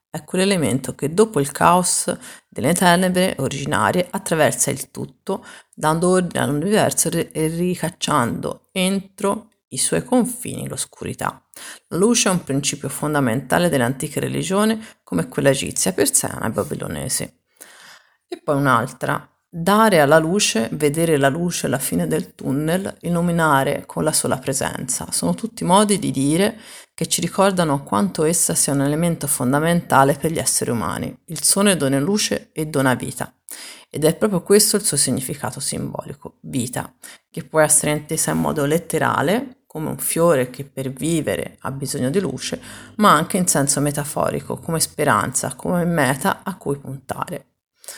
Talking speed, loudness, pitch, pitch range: 145 wpm, -19 LUFS, 160 Hz, 140-185 Hz